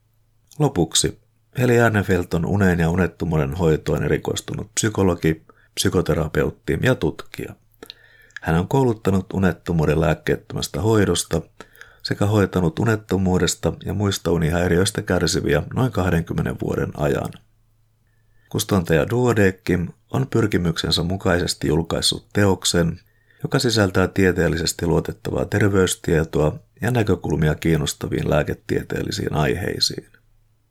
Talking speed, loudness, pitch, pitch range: 90 wpm, -21 LUFS, 95 Hz, 85-110 Hz